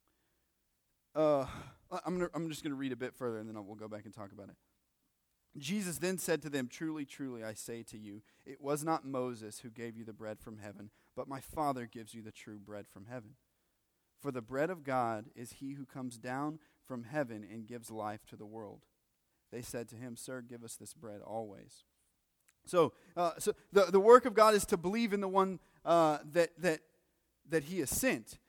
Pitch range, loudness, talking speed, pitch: 110-160 Hz, -34 LUFS, 215 wpm, 130 Hz